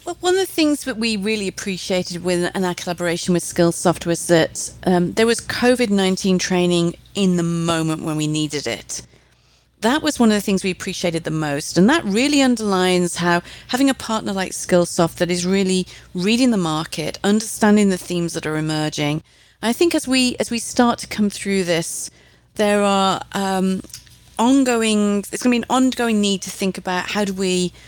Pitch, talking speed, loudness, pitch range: 190 Hz, 195 wpm, -19 LUFS, 175-220 Hz